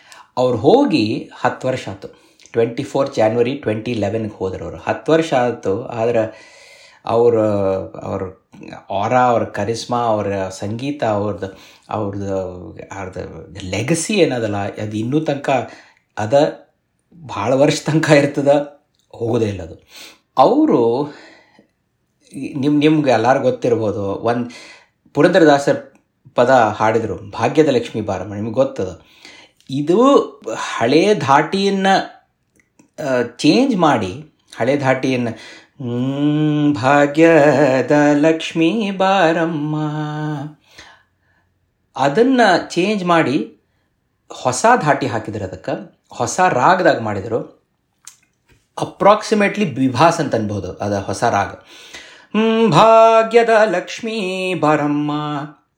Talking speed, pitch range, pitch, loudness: 90 wpm, 110-160 Hz, 140 Hz, -16 LUFS